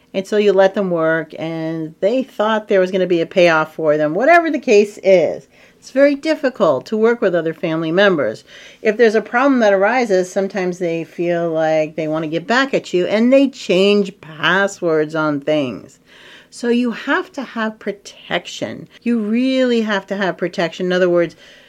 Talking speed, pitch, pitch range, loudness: 185 wpm, 195 Hz, 165-230 Hz, -16 LUFS